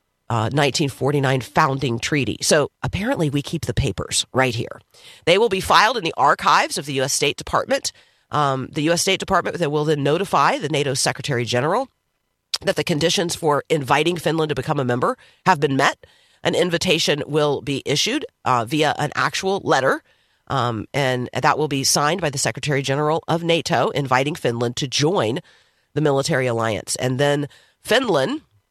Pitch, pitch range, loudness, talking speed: 145 Hz, 130-160 Hz, -20 LUFS, 170 wpm